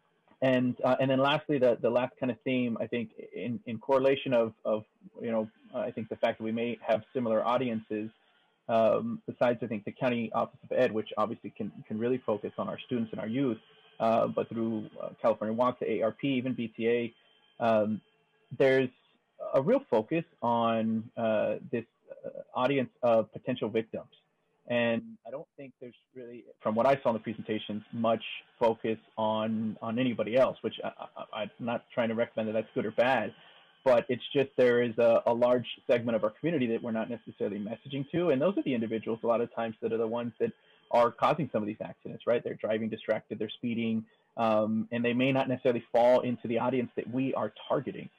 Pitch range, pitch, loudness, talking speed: 110-125 Hz, 115 Hz, -30 LUFS, 205 wpm